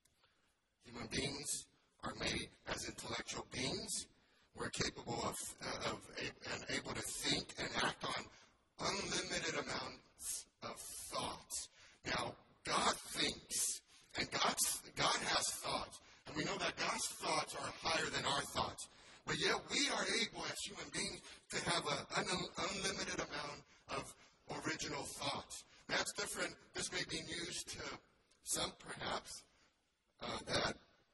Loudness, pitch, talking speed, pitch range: -41 LUFS, 170 Hz, 135 wpm, 145-180 Hz